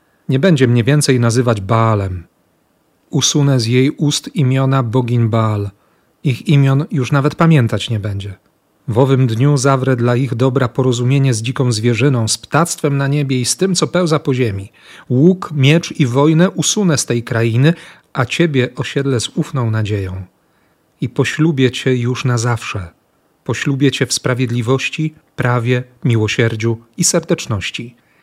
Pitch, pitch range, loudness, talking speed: 130 Hz, 120-145 Hz, -15 LUFS, 150 wpm